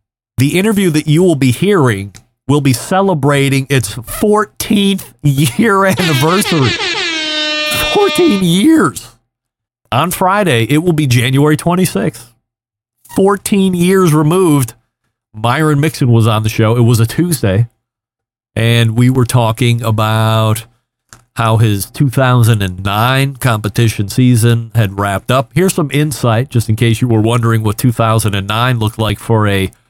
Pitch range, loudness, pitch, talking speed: 115-160 Hz, -12 LUFS, 125 Hz, 130 wpm